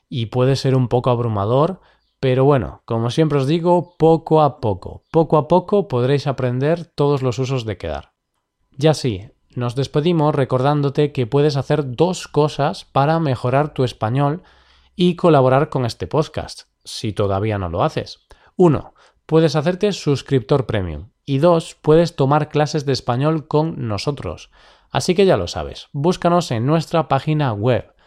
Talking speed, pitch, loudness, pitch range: 155 wpm, 140 Hz, -18 LUFS, 125-155 Hz